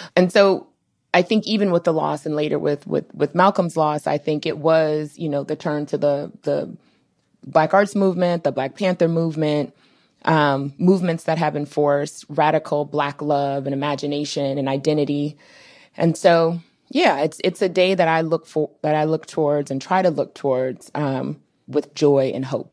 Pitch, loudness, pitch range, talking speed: 150 Hz, -20 LUFS, 145-170 Hz, 185 wpm